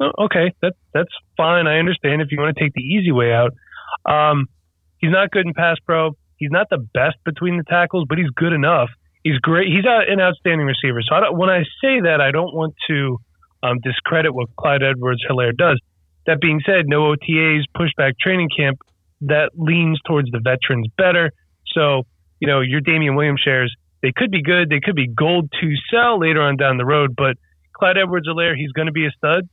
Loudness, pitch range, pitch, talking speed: -17 LUFS, 135-170 Hz, 150 Hz, 205 wpm